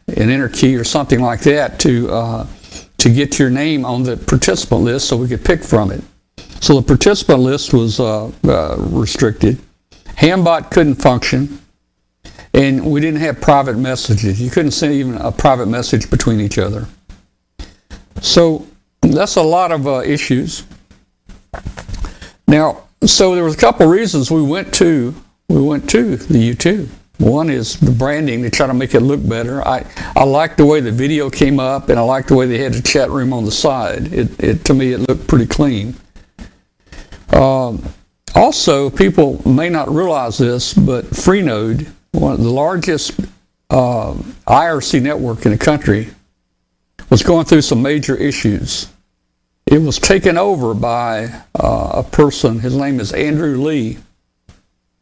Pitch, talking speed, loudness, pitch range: 130 Hz, 165 wpm, -13 LUFS, 115-150 Hz